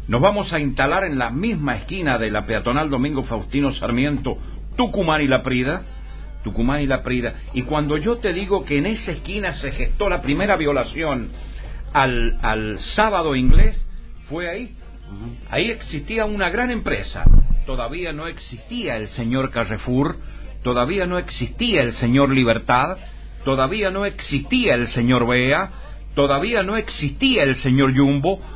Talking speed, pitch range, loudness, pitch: 150 wpm, 120-175 Hz, -20 LUFS, 135 Hz